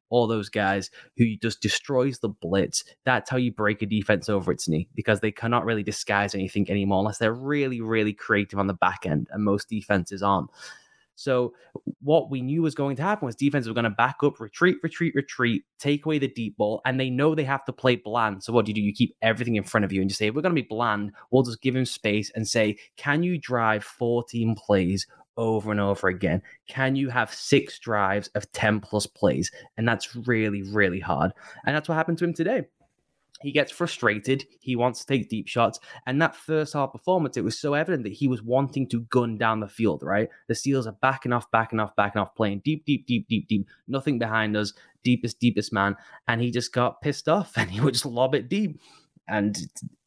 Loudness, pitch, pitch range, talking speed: -25 LUFS, 115 Hz, 105-135 Hz, 225 wpm